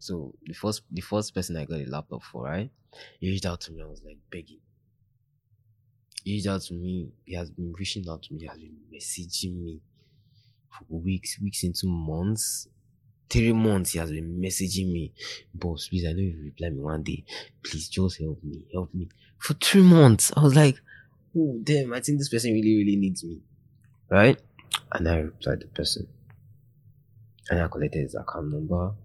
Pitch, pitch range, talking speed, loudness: 95 Hz, 85-115 Hz, 195 wpm, -26 LUFS